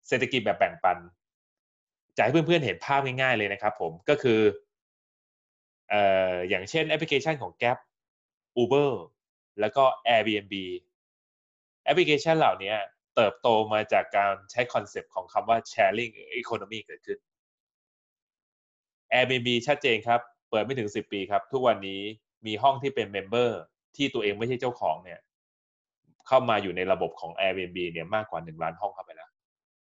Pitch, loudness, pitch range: 120 Hz, -27 LUFS, 100-145 Hz